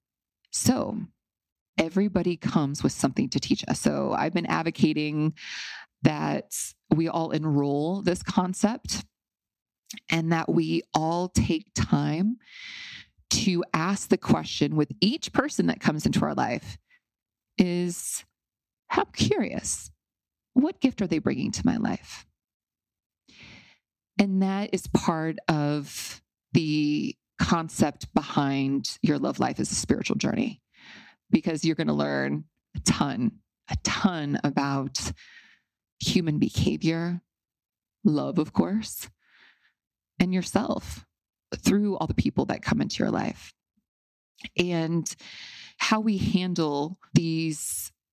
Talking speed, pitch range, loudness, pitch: 115 wpm, 150-200 Hz, -27 LUFS, 170 Hz